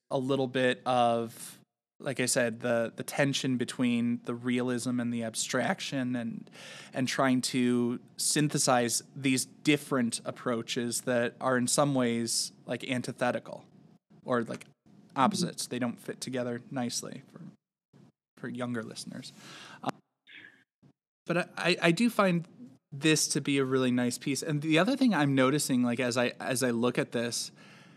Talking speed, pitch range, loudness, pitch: 150 wpm, 120-150 Hz, -30 LUFS, 130 Hz